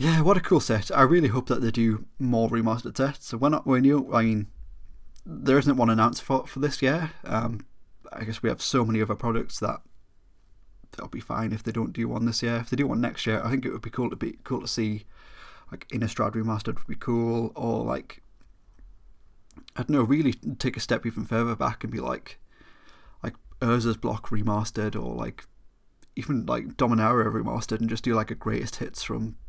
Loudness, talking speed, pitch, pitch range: -26 LUFS, 215 wpm, 115 Hz, 110-125 Hz